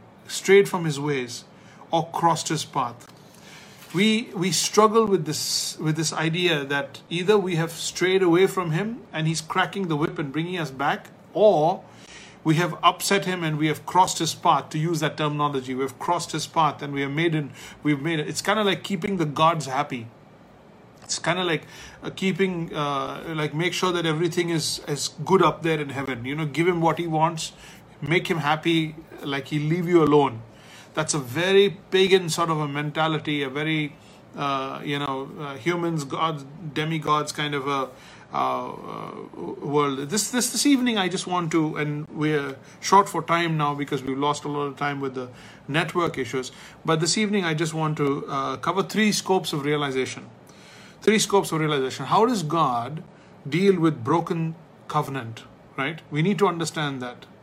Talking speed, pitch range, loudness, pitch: 190 wpm, 145-180 Hz, -24 LUFS, 160 Hz